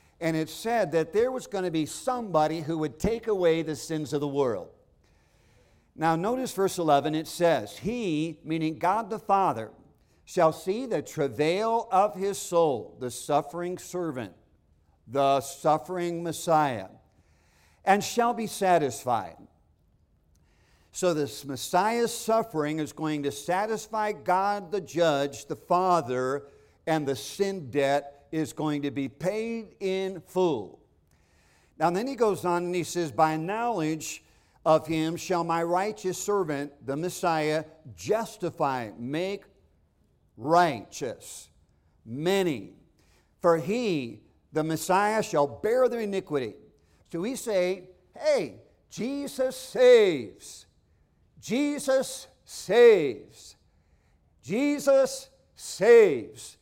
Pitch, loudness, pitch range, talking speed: 165 Hz, -27 LUFS, 140-205 Hz, 120 wpm